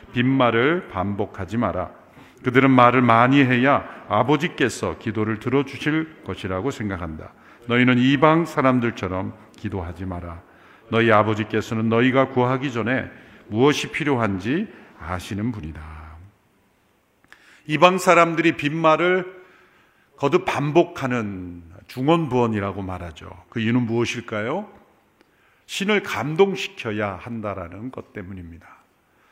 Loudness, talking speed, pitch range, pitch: -21 LUFS, 275 characters per minute, 100-140 Hz, 115 Hz